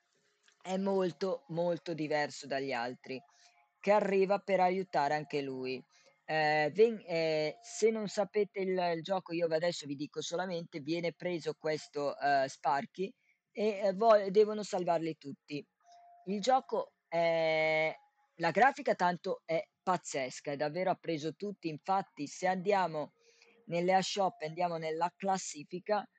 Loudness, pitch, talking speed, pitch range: -33 LUFS, 175 Hz, 130 wpm, 155-195 Hz